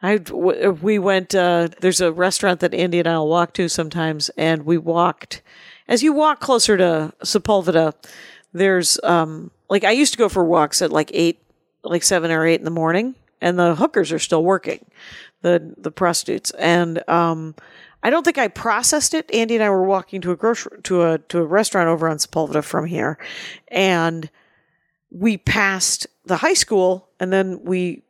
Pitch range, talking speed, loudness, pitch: 165-195 Hz, 185 wpm, -18 LUFS, 175 Hz